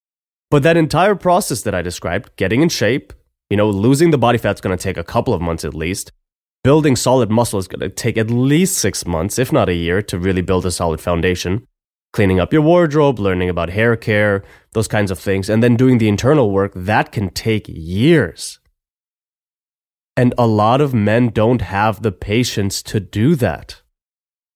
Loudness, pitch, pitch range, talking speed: -16 LUFS, 105 Hz, 95-125 Hz, 200 wpm